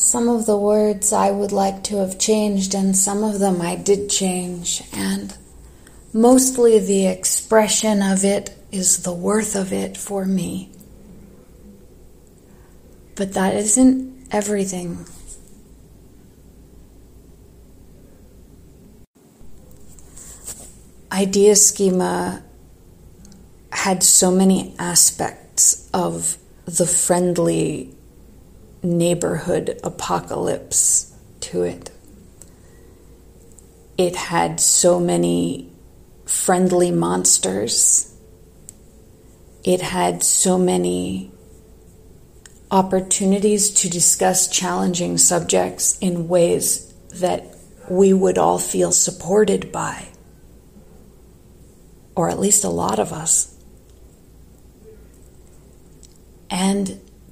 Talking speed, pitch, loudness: 85 wpm, 180 Hz, -17 LUFS